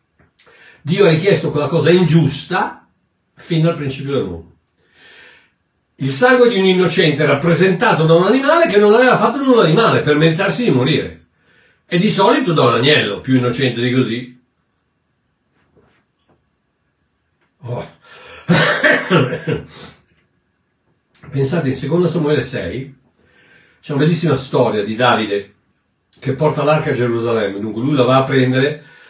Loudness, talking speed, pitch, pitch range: -14 LUFS, 130 wpm, 145 Hz, 125-170 Hz